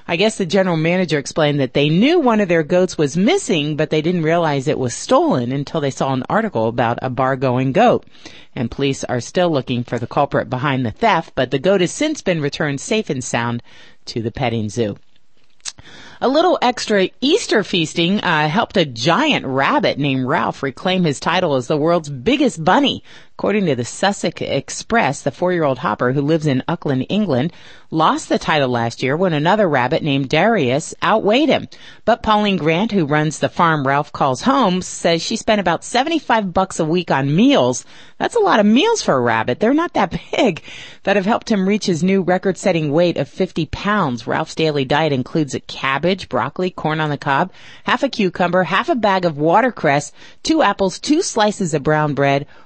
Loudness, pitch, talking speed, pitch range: -17 LUFS, 165 Hz, 195 wpm, 140-195 Hz